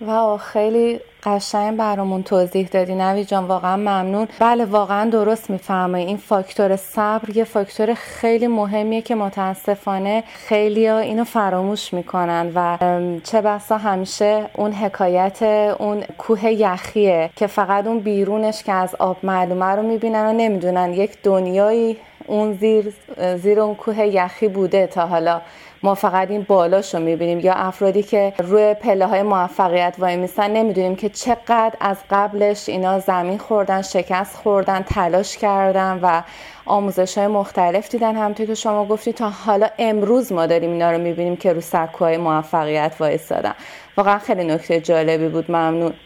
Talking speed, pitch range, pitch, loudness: 150 wpm, 185-215 Hz, 200 Hz, -18 LUFS